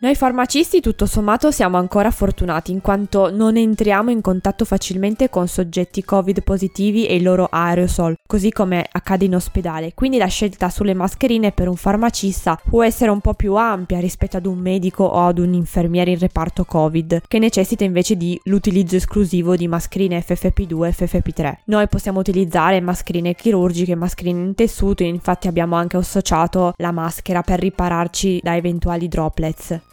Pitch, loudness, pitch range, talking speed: 185 Hz, -18 LUFS, 175-205 Hz, 165 wpm